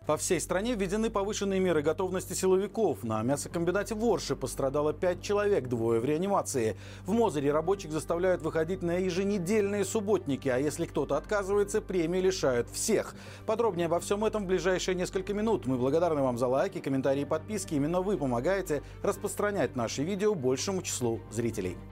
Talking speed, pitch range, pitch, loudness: 155 wpm, 135-200 Hz, 180 Hz, -30 LUFS